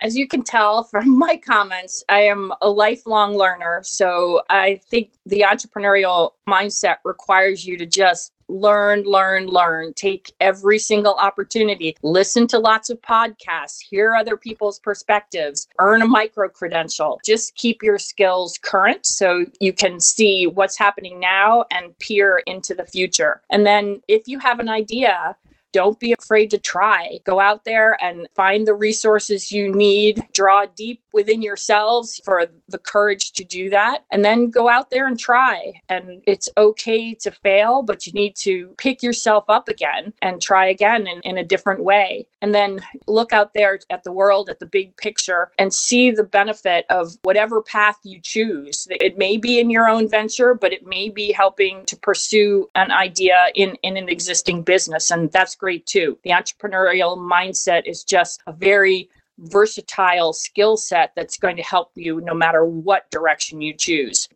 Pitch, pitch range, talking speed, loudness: 200 Hz, 185-215 Hz, 170 wpm, -17 LUFS